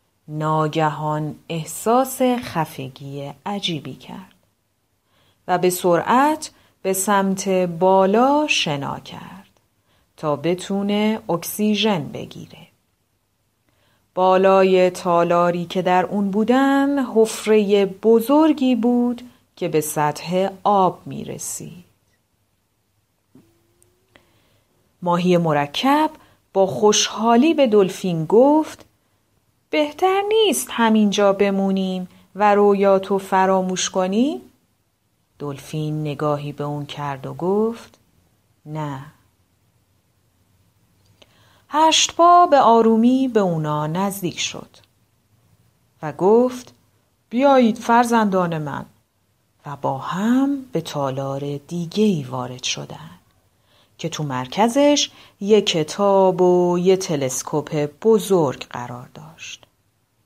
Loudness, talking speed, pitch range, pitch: -19 LUFS, 90 wpm, 135-215 Hz, 180 Hz